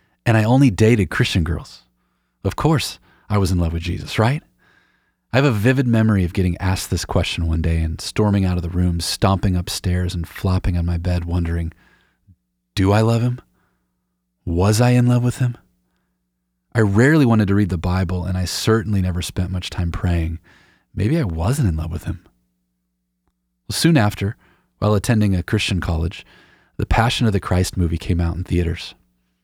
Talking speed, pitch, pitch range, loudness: 185 wpm, 90 Hz, 85-105 Hz, -19 LUFS